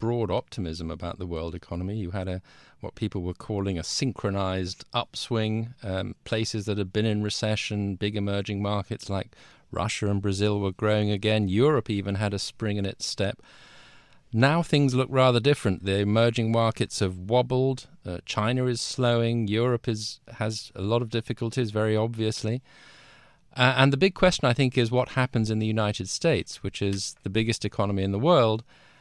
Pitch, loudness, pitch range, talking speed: 110 Hz, -26 LUFS, 100-120 Hz, 180 wpm